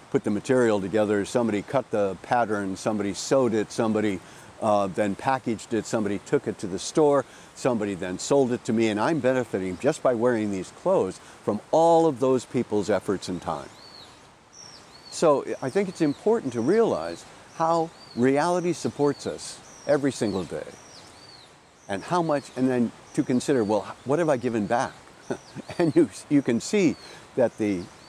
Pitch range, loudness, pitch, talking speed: 105-145 Hz, -25 LUFS, 125 Hz, 165 wpm